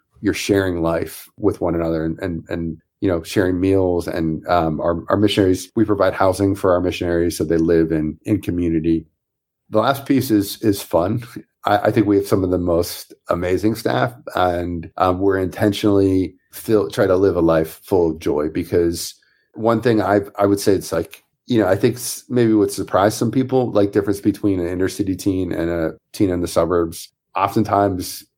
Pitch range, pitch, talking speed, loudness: 85-100 Hz, 95 Hz, 195 wpm, -19 LUFS